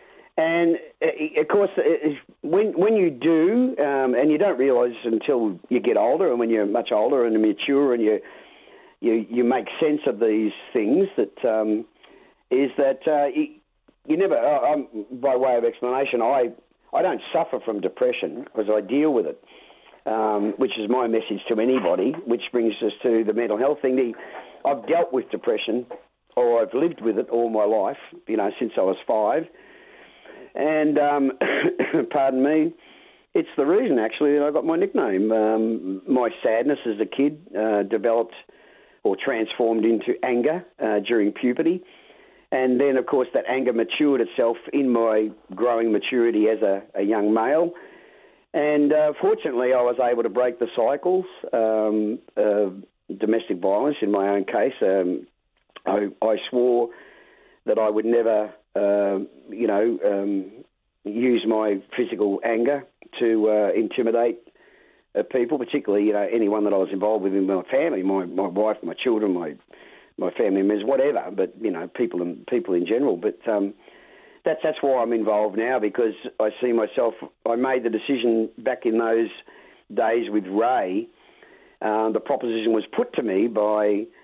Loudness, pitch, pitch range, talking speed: -22 LUFS, 115 Hz, 110-145 Hz, 165 wpm